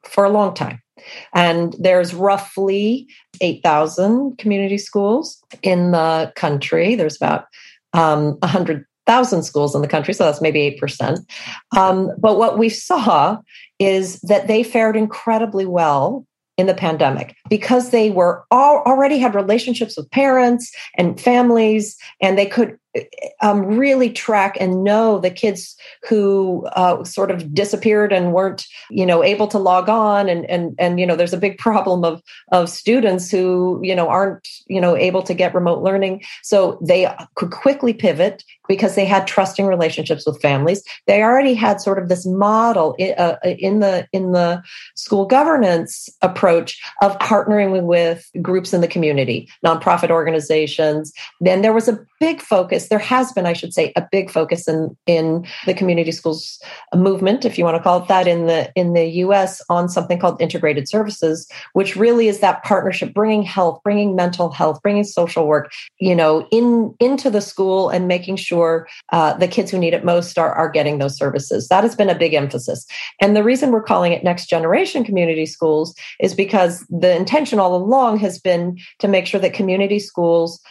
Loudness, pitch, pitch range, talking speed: -17 LUFS, 190 Hz, 170-210 Hz, 175 wpm